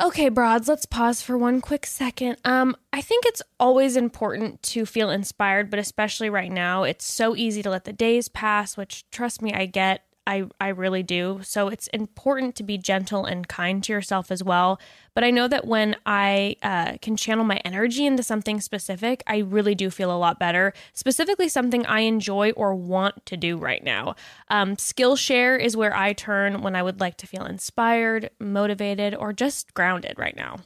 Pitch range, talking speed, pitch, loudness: 195-240 Hz, 195 wpm, 210 Hz, -23 LUFS